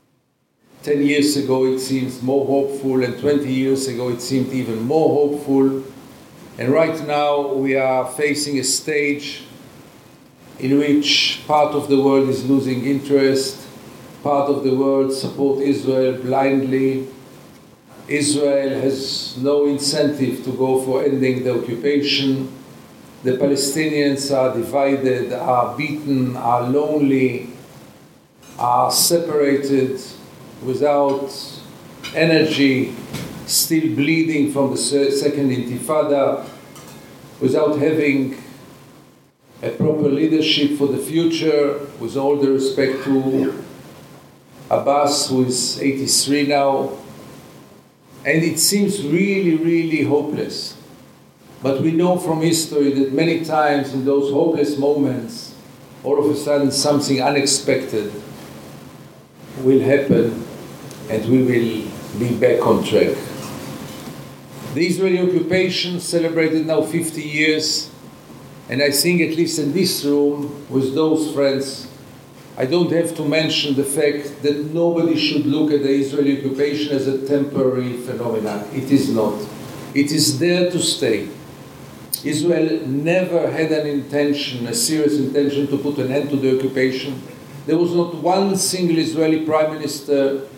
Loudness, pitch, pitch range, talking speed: -18 LUFS, 140 Hz, 135-150 Hz, 125 wpm